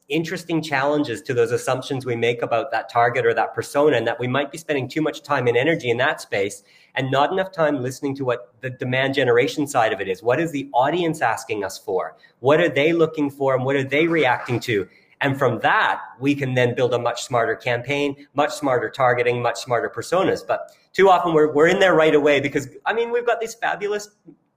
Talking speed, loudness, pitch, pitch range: 225 wpm, -21 LUFS, 145 Hz, 125-160 Hz